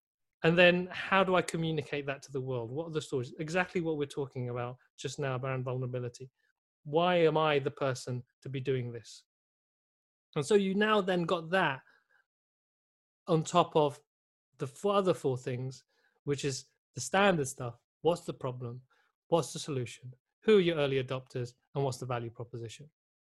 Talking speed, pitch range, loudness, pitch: 175 wpm, 125-165 Hz, -31 LUFS, 140 Hz